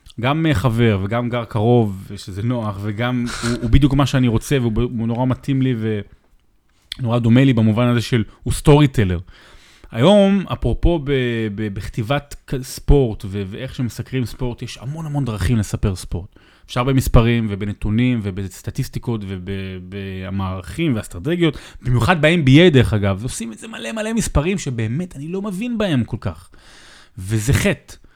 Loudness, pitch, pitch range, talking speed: -19 LUFS, 120 Hz, 105-135 Hz, 145 wpm